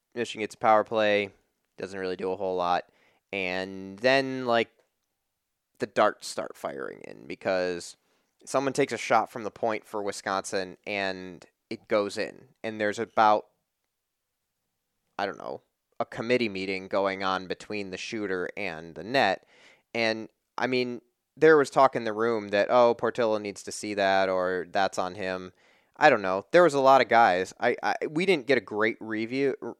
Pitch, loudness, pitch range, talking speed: 105 Hz, -26 LUFS, 95-115 Hz, 175 wpm